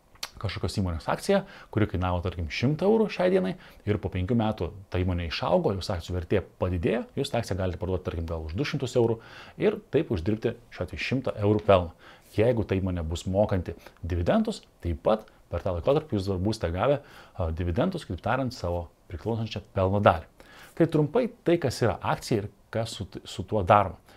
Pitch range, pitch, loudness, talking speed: 90-120 Hz, 105 Hz, -28 LUFS, 175 wpm